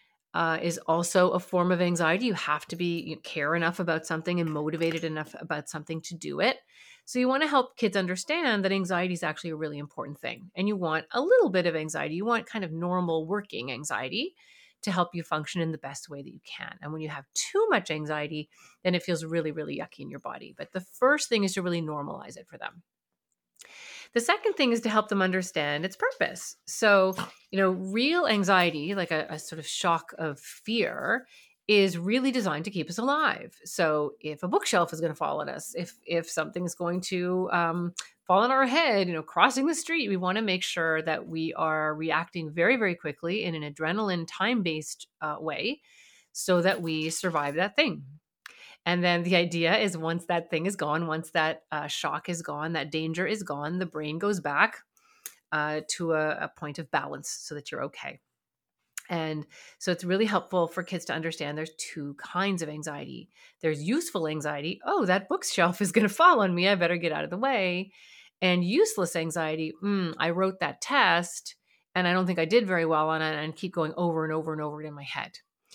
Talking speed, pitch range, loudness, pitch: 215 wpm, 160-195 Hz, -28 LUFS, 175 Hz